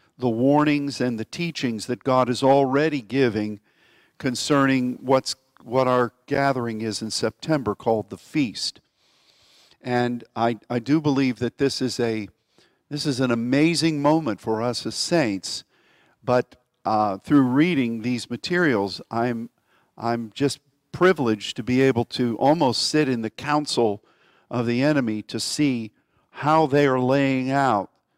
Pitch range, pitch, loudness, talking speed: 115-140 Hz, 125 Hz, -23 LUFS, 145 wpm